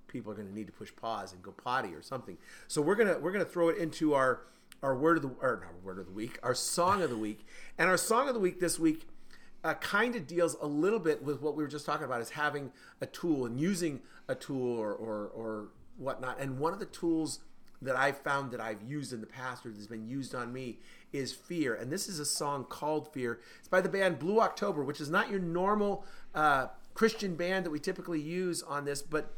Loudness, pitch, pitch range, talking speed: -33 LUFS, 150 Hz, 125-175 Hz, 250 wpm